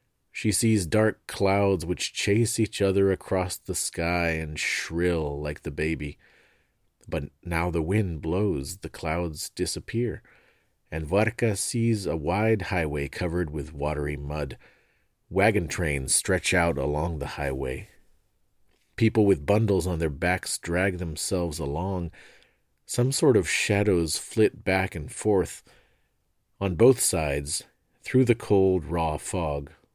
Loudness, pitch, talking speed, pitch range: -26 LUFS, 90 Hz, 130 wpm, 80-100 Hz